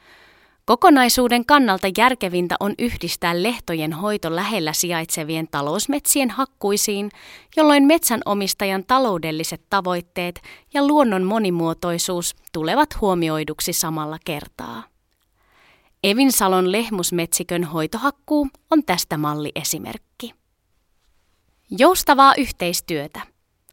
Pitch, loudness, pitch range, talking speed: 185 Hz, -19 LUFS, 160-245 Hz, 80 wpm